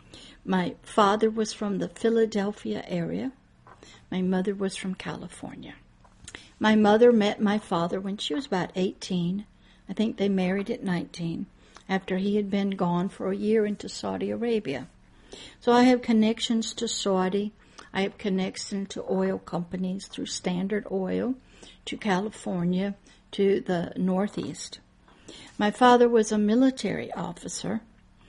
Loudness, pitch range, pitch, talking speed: -26 LUFS, 185-220 Hz, 200 Hz, 140 wpm